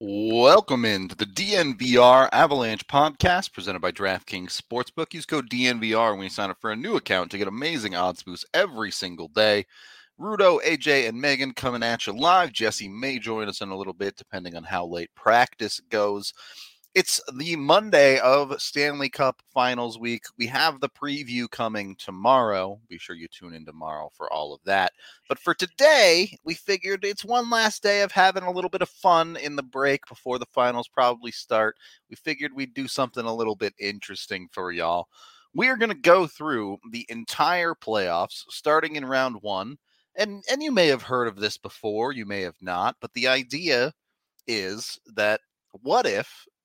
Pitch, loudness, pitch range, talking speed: 125 Hz, -23 LUFS, 105-155 Hz, 185 wpm